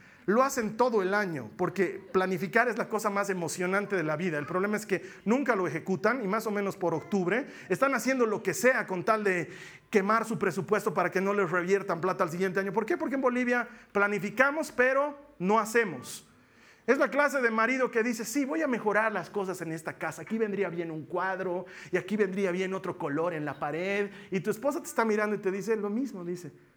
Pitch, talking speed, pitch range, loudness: 200 Hz, 220 wpm, 185-230 Hz, -29 LUFS